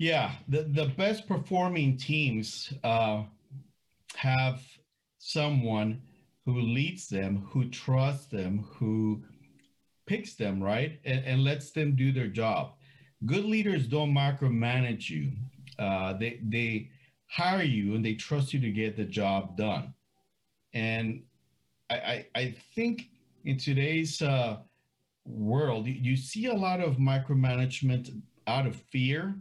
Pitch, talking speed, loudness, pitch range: 130 Hz, 130 wpm, -30 LUFS, 110-145 Hz